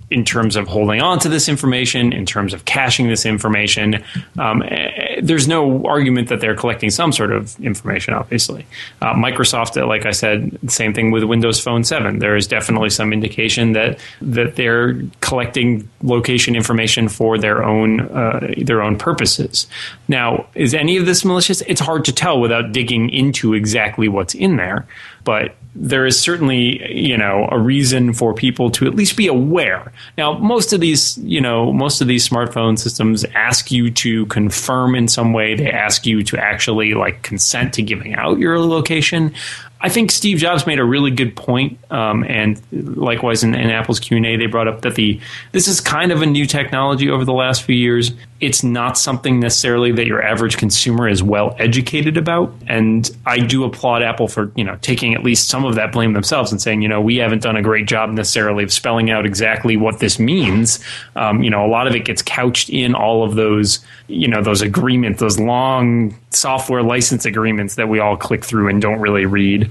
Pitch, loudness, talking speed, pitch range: 120 Hz, -15 LUFS, 195 wpm, 110-130 Hz